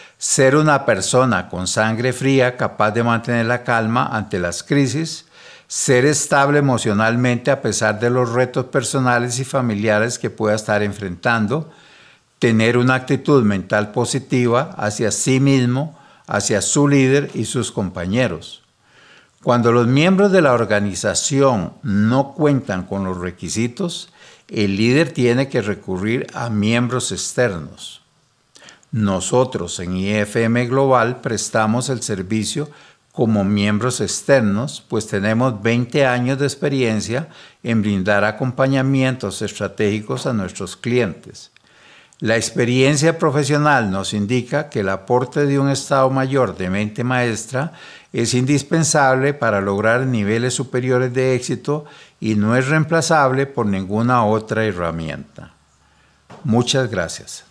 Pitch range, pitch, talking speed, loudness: 105-135 Hz, 120 Hz, 125 wpm, -18 LUFS